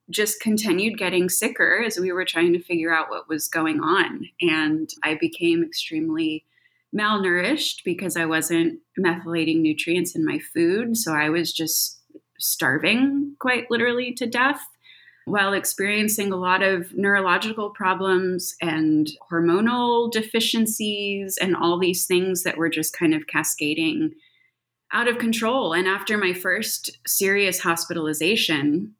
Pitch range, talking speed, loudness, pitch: 170-240 Hz, 135 wpm, -22 LUFS, 195 Hz